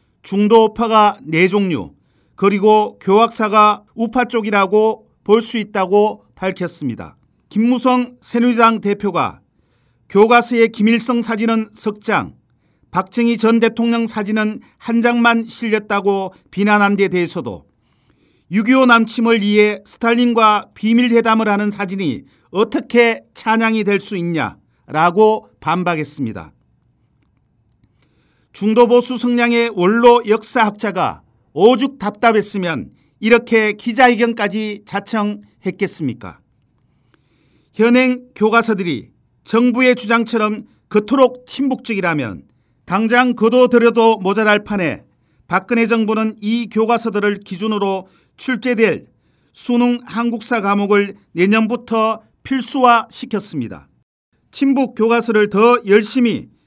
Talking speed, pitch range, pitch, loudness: 250 characters per minute, 200-235 Hz, 220 Hz, -15 LUFS